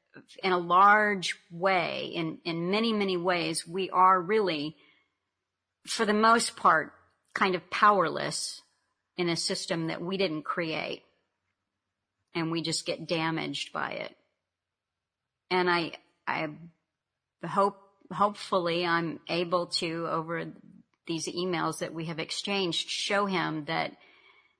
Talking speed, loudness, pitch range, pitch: 125 wpm, -28 LUFS, 165-195 Hz, 175 Hz